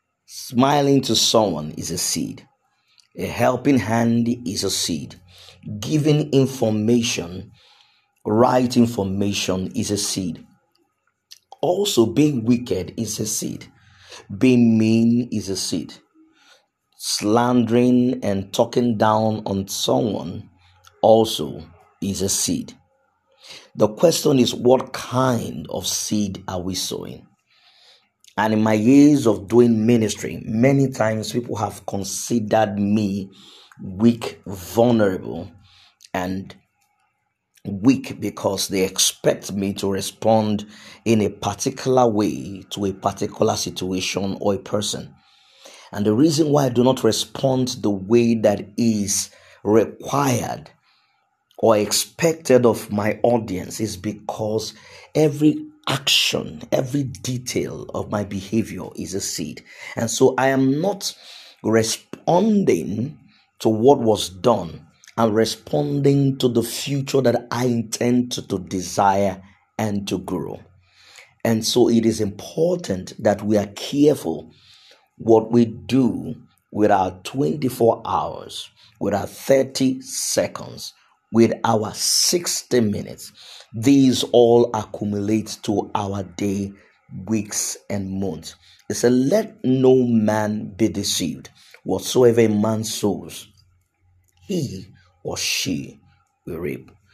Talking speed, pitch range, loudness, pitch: 115 wpm, 100-125 Hz, -20 LUFS, 110 Hz